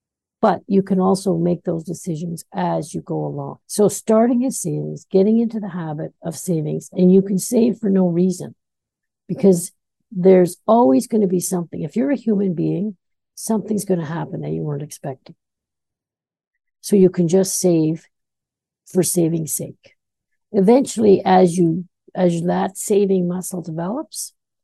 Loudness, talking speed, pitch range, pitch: -19 LUFS, 155 wpm, 170-205 Hz, 185 Hz